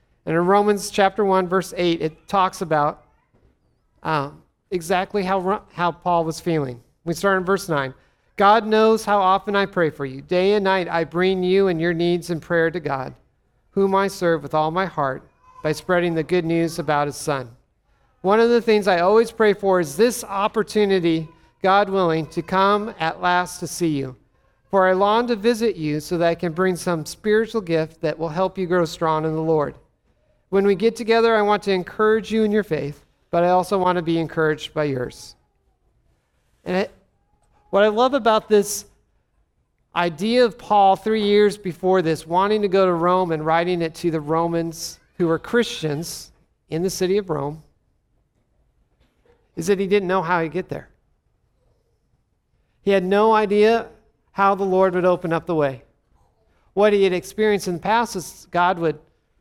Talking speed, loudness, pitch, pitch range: 190 wpm, -20 LUFS, 180 Hz, 160-200 Hz